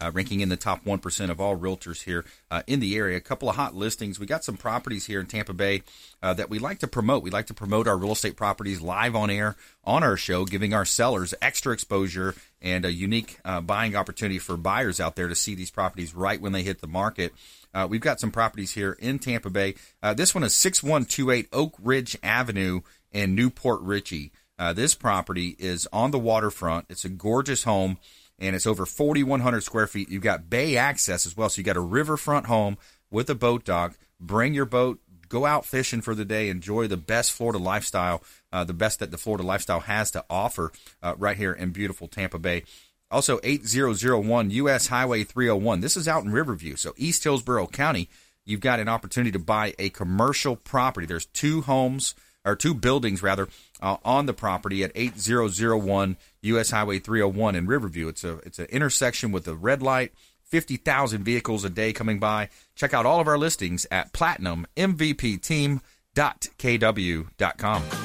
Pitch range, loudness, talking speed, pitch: 95-120 Hz, -25 LUFS, 195 wpm, 105 Hz